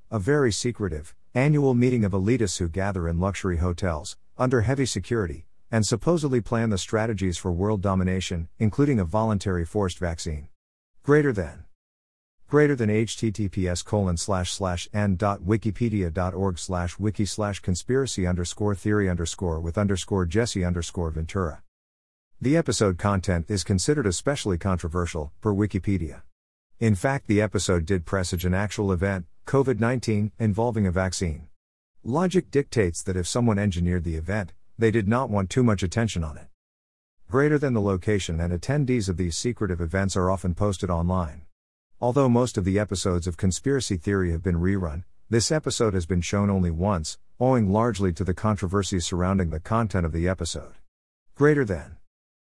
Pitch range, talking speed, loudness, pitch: 90-110 Hz, 150 wpm, -25 LUFS, 95 Hz